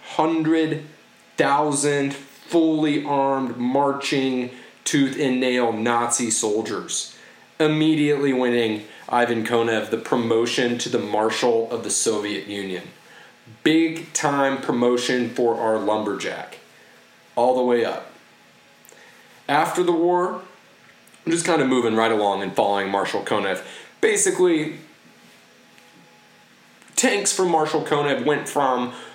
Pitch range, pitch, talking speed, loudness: 115-155 Hz, 135 Hz, 110 wpm, -21 LUFS